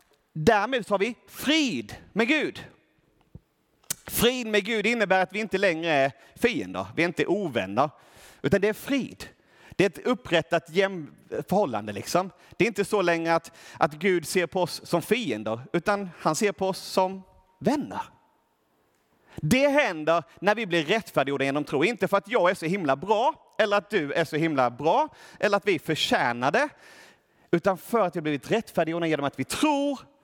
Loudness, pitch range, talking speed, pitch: -26 LUFS, 165-215 Hz, 175 wpm, 190 Hz